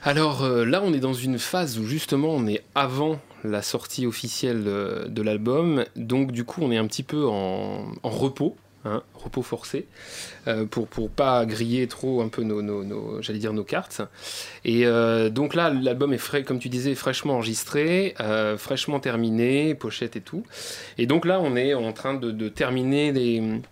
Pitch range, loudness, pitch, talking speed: 110-140 Hz, -25 LUFS, 125 Hz, 195 wpm